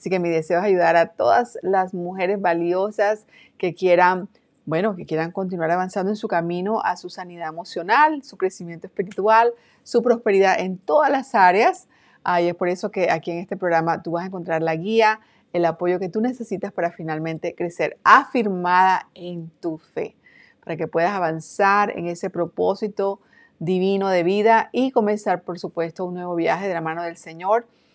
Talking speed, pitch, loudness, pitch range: 180 wpm, 185 Hz, -21 LUFS, 170-210 Hz